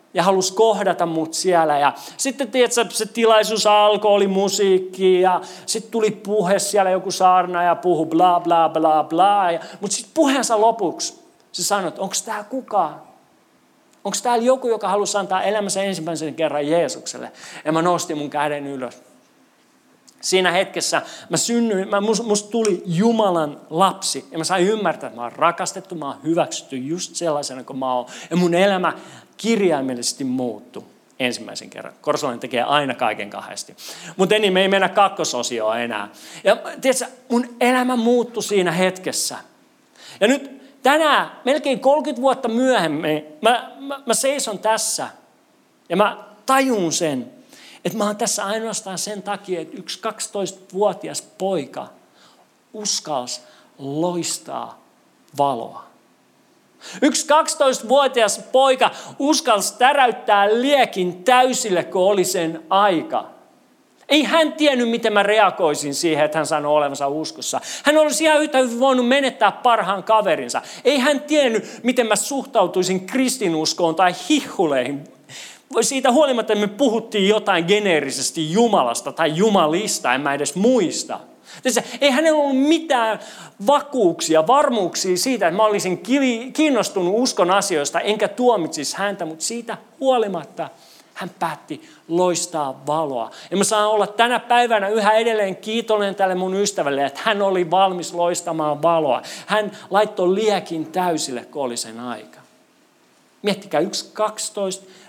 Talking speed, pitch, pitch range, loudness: 140 wpm, 200 Hz, 170-235 Hz, -19 LUFS